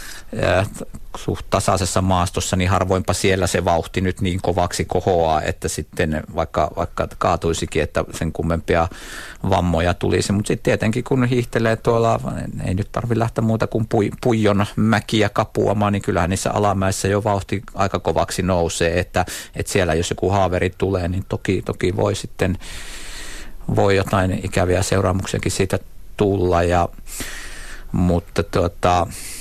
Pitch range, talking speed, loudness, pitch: 90-105 Hz, 135 wpm, -20 LUFS, 95 Hz